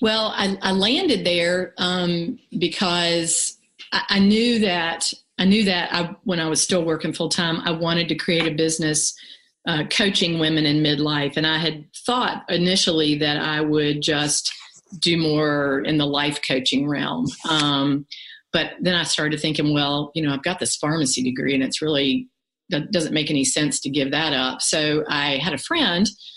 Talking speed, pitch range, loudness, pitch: 180 wpm, 150-180 Hz, -21 LUFS, 160 Hz